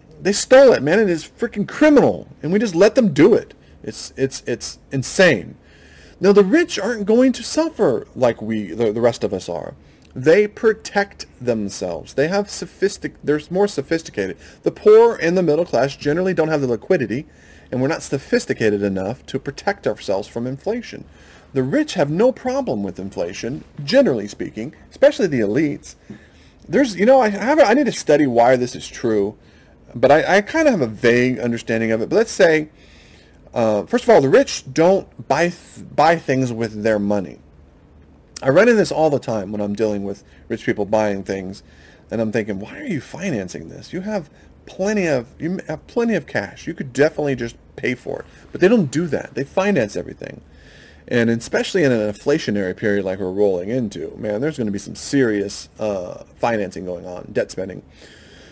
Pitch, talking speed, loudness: 135 Hz, 190 wpm, -18 LUFS